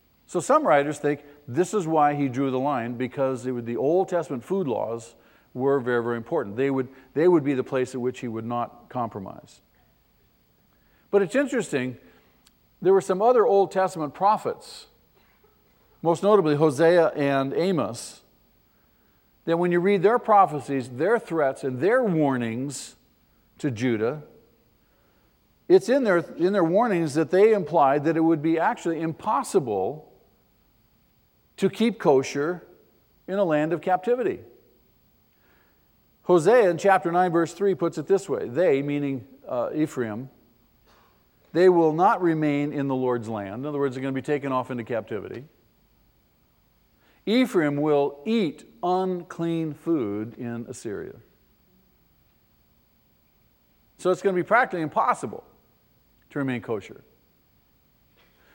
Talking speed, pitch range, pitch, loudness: 140 wpm, 130-185 Hz, 150 Hz, -24 LUFS